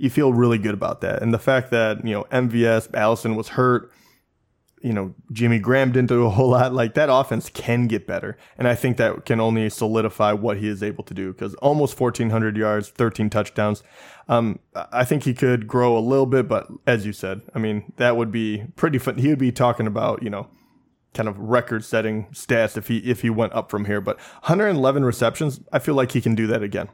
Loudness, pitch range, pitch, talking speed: -21 LUFS, 110-125 Hz, 115 Hz, 230 wpm